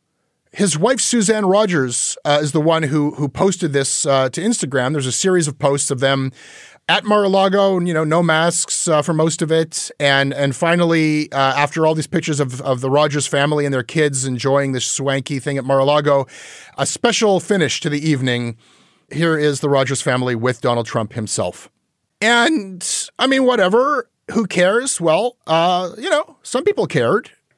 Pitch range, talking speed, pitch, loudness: 135-180 Hz, 180 wpm, 150 Hz, -17 LUFS